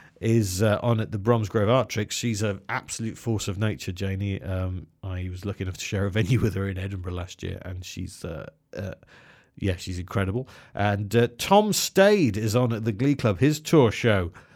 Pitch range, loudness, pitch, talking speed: 95-120 Hz, -25 LUFS, 105 Hz, 205 wpm